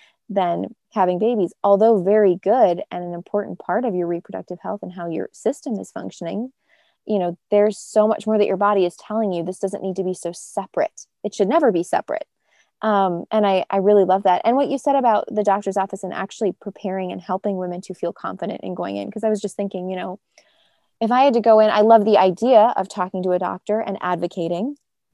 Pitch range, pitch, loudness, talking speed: 180-215 Hz, 195 Hz, -20 LUFS, 225 wpm